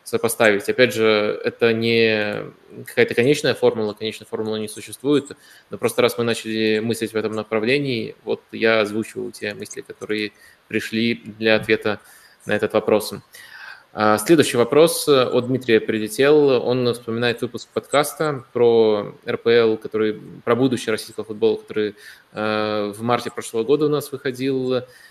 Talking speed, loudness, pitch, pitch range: 135 wpm, -20 LUFS, 115 Hz, 110-125 Hz